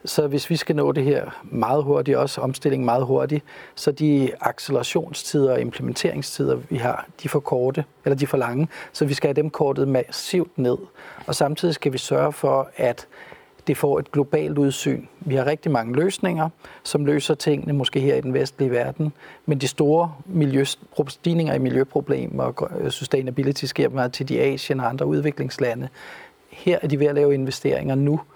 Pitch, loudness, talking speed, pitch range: 145 Hz, -22 LUFS, 185 wpm, 135-155 Hz